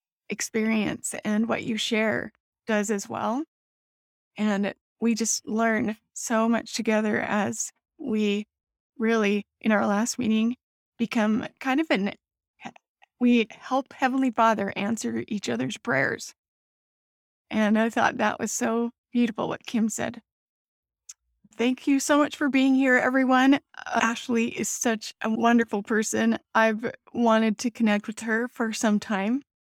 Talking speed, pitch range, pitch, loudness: 140 wpm, 215-245 Hz, 225 Hz, -25 LUFS